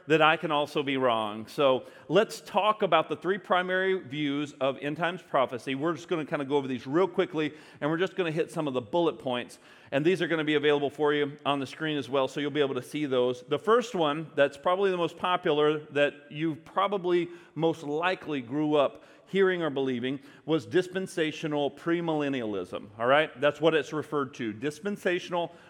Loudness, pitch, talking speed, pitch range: -28 LUFS, 150 Hz, 210 wpm, 140-175 Hz